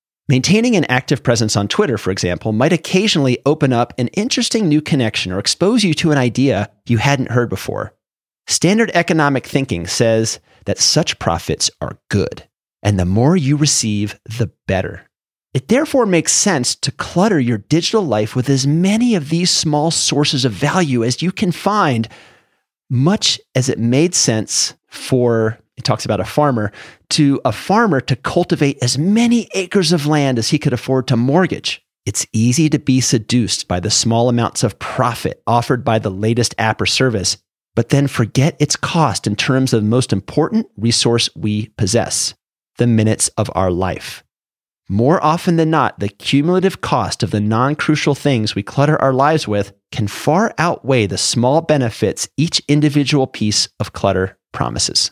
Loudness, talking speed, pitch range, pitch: -16 LUFS, 170 wpm, 110-155 Hz, 130 Hz